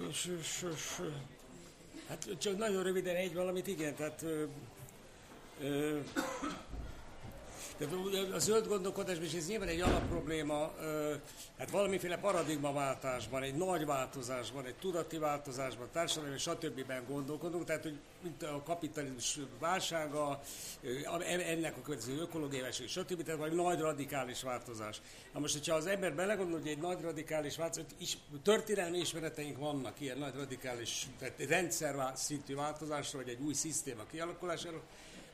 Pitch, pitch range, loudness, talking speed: 155 Hz, 140-170 Hz, -38 LUFS, 125 wpm